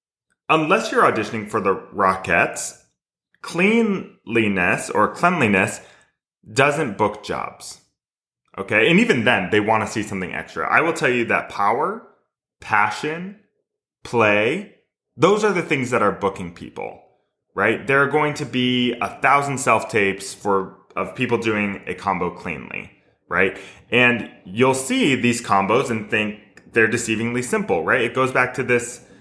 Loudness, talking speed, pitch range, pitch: -20 LUFS, 150 wpm, 100-135 Hz, 120 Hz